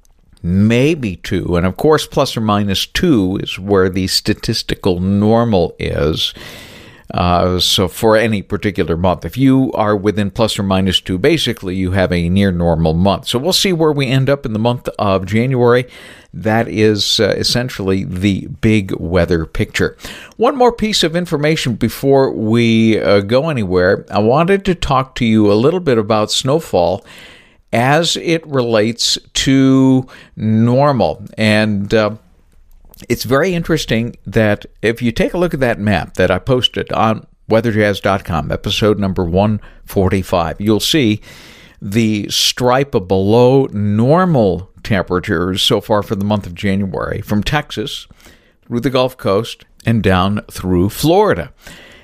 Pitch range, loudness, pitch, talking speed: 95-125 Hz, -14 LUFS, 110 Hz, 150 wpm